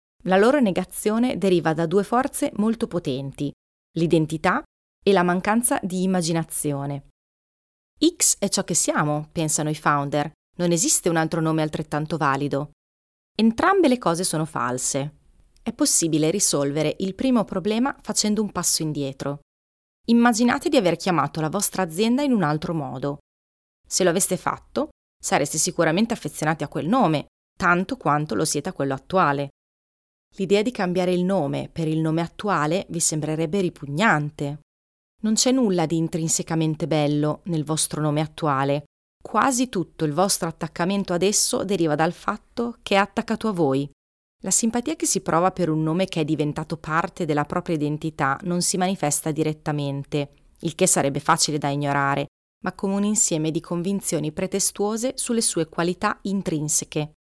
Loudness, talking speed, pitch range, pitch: -22 LUFS, 155 wpm, 150-200 Hz, 170 Hz